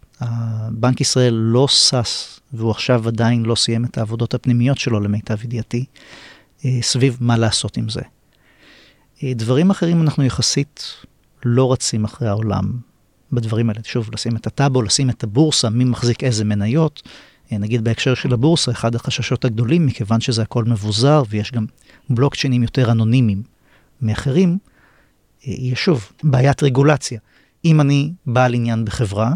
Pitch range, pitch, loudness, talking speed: 115-135 Hz, 120 Hz, -18 LUFS, 135 wpm